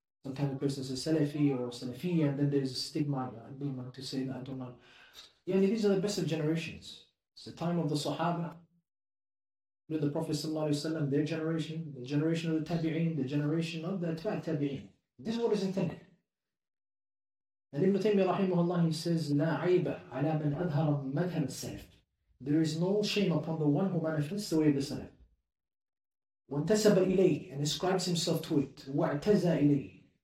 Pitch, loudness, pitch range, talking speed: 155 Hz, -32 LUFS, 140-170 Hz, 165 wpm